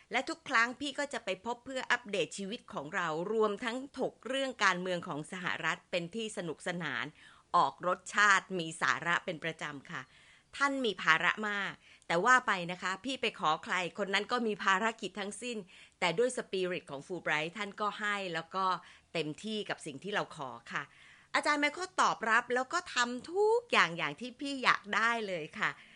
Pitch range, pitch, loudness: 180-245 Hz, 205 Hz, -33 LUFS